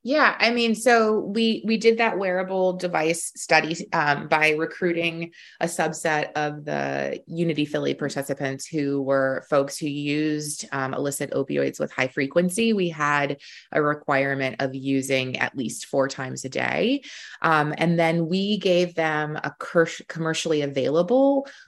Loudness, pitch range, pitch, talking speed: -23 LUFS, 140-180 Hz, 155 Hz, 150 wpm